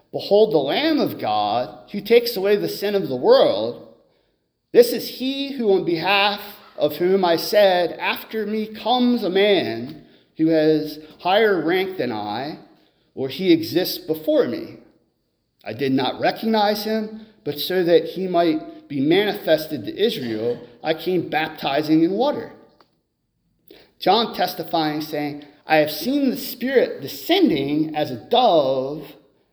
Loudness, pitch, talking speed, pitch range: -20 LUFS, 185 Hz, 140 wpm, 155-235 Hz